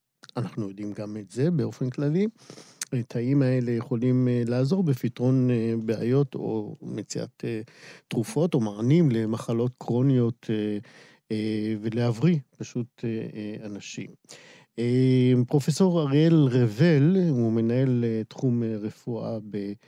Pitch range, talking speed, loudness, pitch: 110-135 Hz, 95 wpm, -25 LUFS, 120 Hz